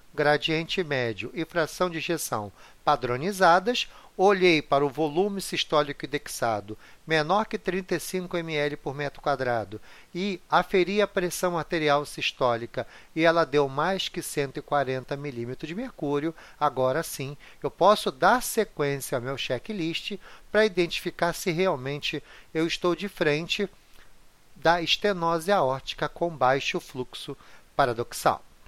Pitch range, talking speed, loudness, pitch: 145-180 Hz, 125 wpm, -26 LUFS, 160 Hz